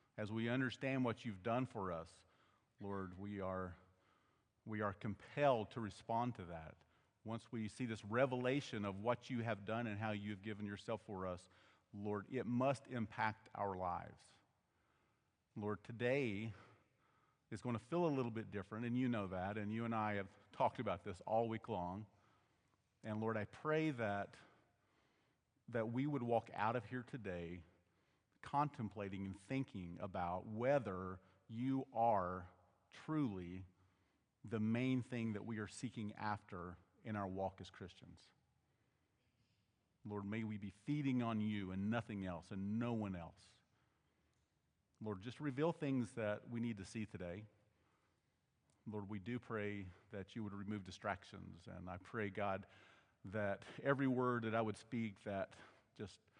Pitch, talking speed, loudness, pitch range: 105 Hz, 155 wpm, -44 LUFS, 100-120 Hz